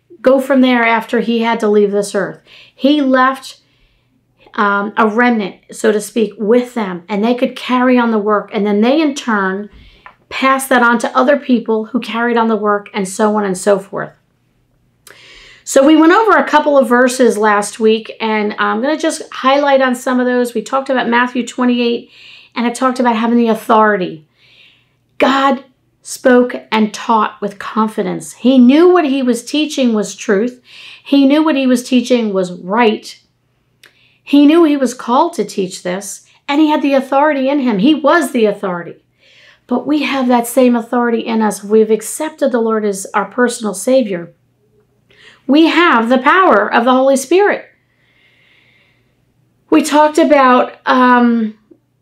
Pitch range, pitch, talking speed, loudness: 215-270 Hz, 240 Hz, 175 wpm, -13 LUFS